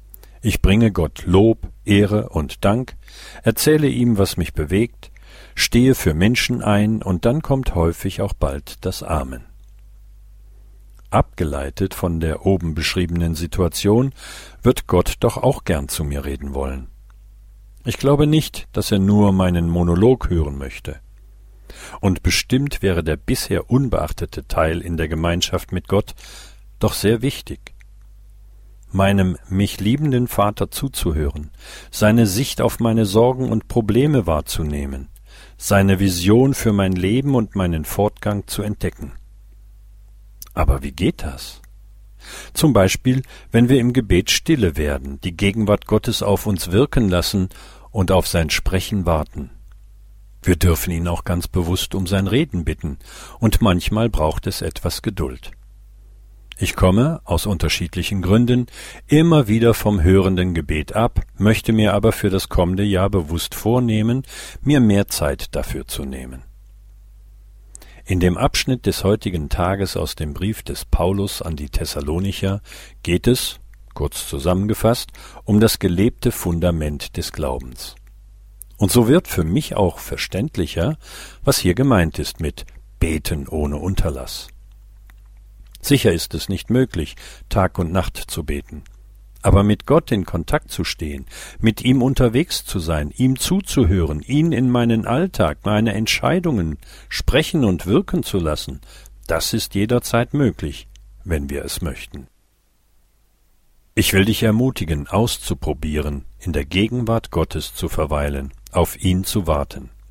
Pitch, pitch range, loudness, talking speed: 100 Hz, 85-110 Hz, -19 LUFS, 135 wpm